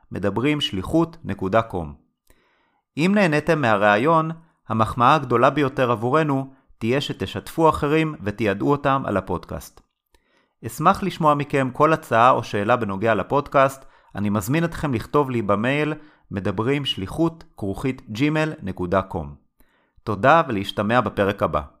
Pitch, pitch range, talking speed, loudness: 130 Hz, 105-150 Hz, 100 wpm, -21 LUFS